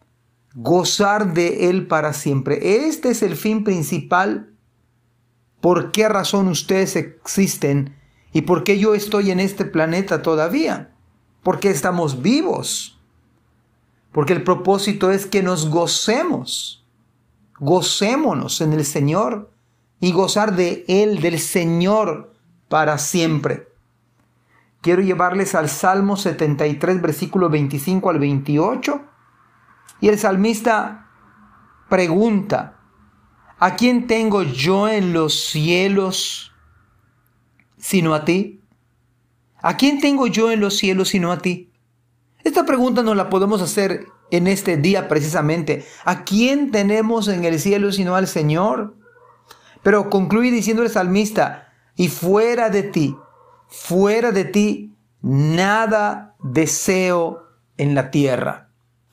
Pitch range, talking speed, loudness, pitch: 150-200 Hz, 115 wpm, -18 LUFS, 180 Hz